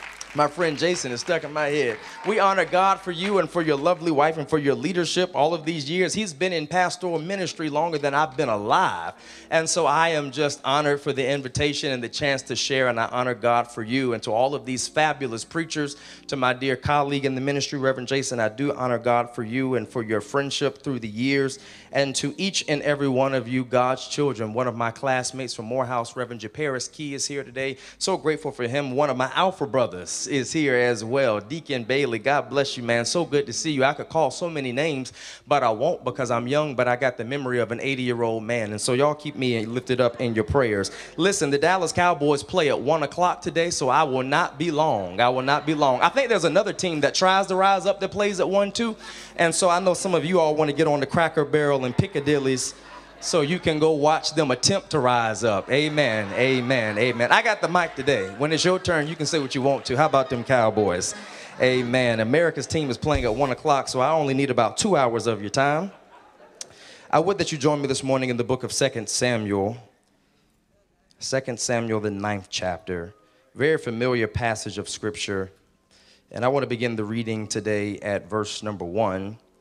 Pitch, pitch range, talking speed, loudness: 135 Hz, 120-155 Hz, 225 wpm, -23 LUFS